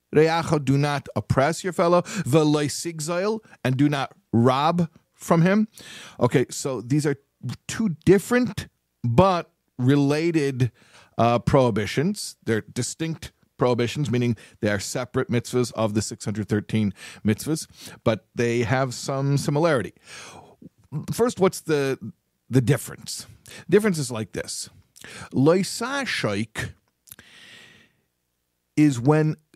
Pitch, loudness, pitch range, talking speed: 140 Hz, -23 LUFS, 120-165 Hz, 105 wpm